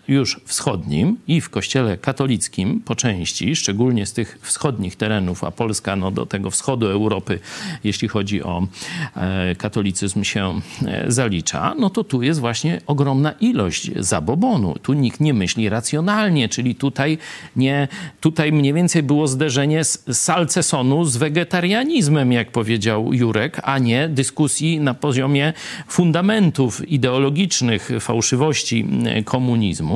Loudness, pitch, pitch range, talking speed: -19 LUFS, 130 Hz, 110-155 Hz, 130 wpm